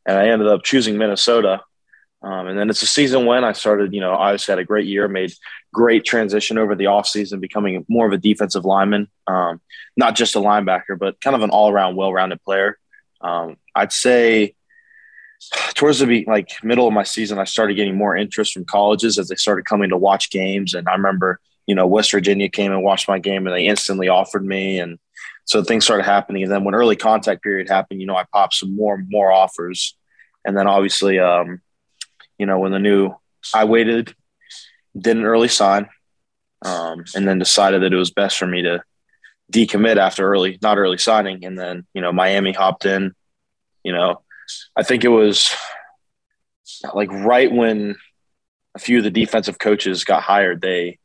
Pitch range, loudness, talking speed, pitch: 95-110 Hz, -17 LUFS, 195 wpm, 100 Hz